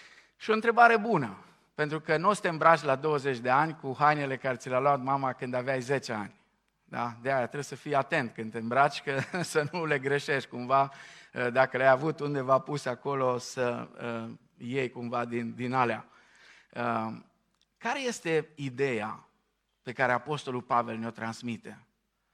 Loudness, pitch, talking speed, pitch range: -29 LUFS, 135 Hz, 175 wpm, 120-150 Hz